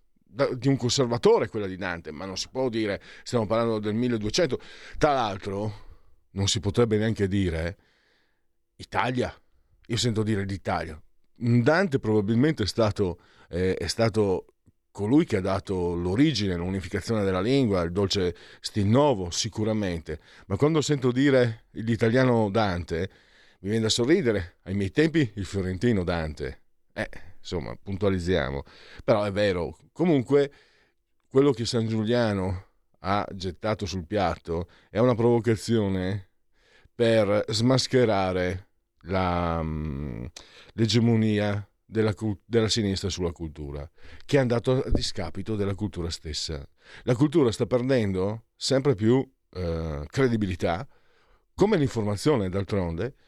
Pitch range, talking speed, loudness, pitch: 90-120 Hz, 125 wpm, -26 LUFS, 105 Hz